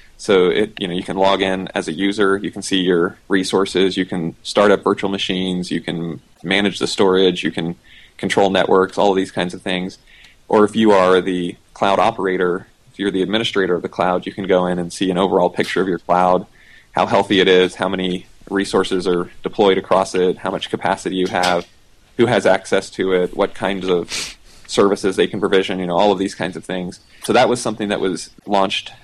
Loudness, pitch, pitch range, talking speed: -18 LUFS, 95 Hz, 90-100 Hz, 220 wpm